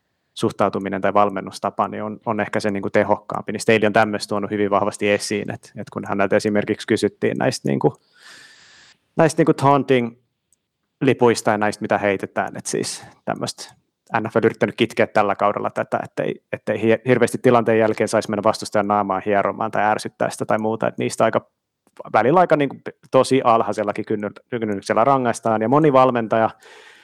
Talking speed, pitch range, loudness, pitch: 175 wpm, 105-120 Hz, -20 LUFS, 110 Hz